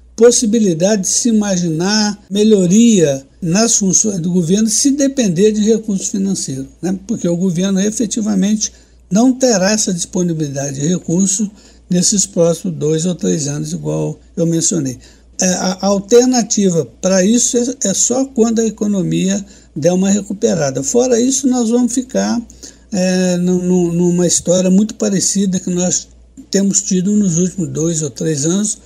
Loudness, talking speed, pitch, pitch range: -14 LUFS, 135 wpm, 195 Hz, 175-220 Hz